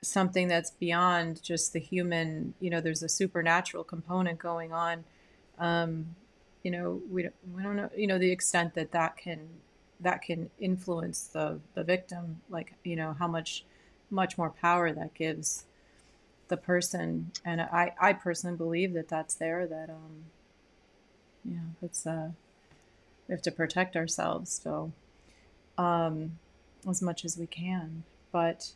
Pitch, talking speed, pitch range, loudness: 170 Hz, 150 wpm, 165-180 Hz, -32 LUFS